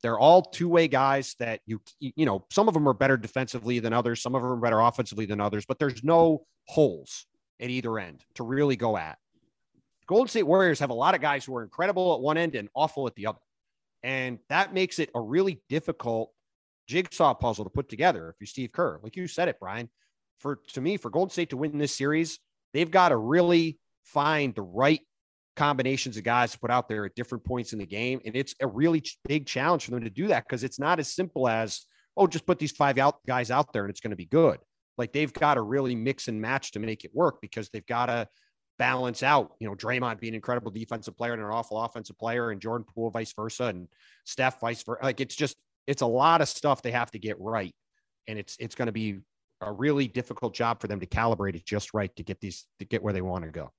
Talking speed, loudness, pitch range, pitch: 245 wpm, -27 LUFS, 110-145 Hz, 125 Hz